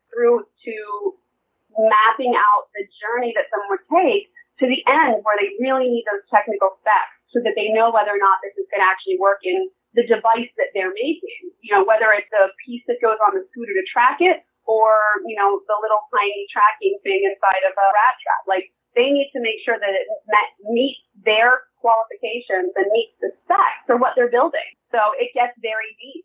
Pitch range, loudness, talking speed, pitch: 210-280 Hz, -19 LUFS, 205 wpm, 230 Hz